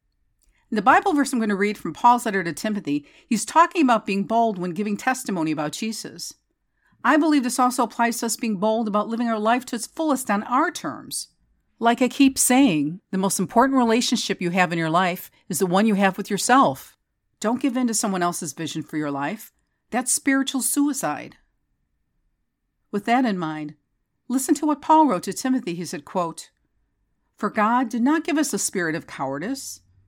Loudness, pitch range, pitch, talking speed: -22 LUFS, 190-260 Hz, 225 Hz, 195 wpm